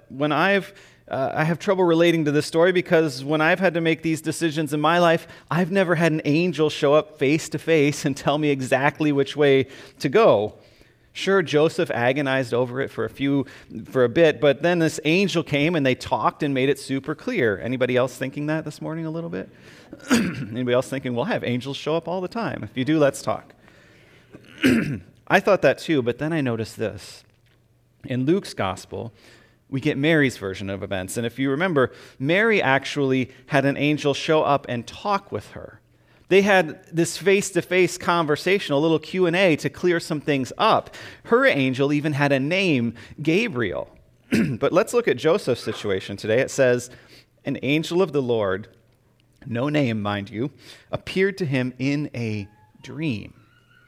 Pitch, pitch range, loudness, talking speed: 145 Hz, 125-165 Hz, -22 LUFS, 185 wpm